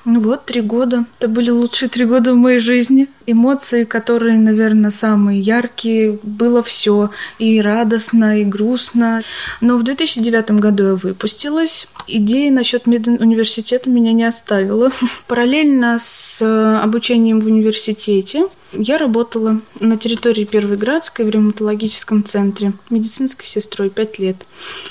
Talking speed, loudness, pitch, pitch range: 130 wpm, -14 LUFS, 230 Hz, 215-245 Hz